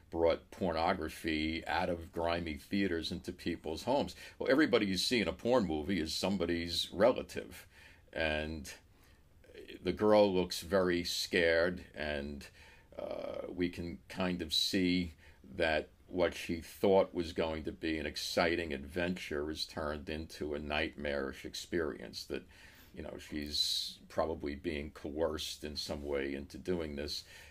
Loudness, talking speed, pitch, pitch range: -35 LUFS, 135 wpm, 85 Hz, 75-90 Hz